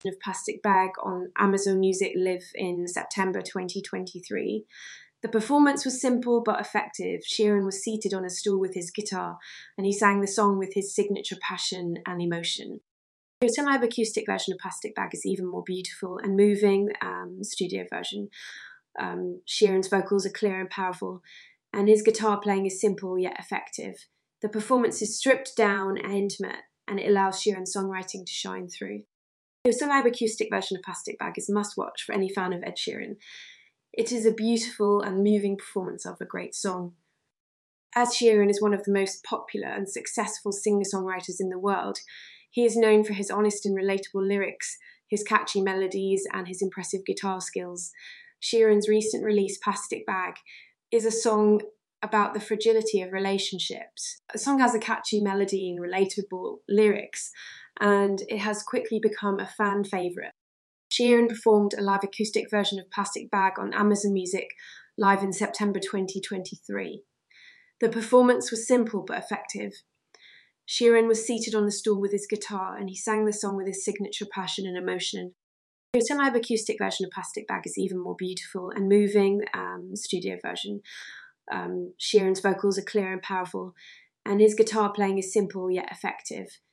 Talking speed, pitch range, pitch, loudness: 170 wpm, 190-215 Hz, 200 Hz, -27 LUFS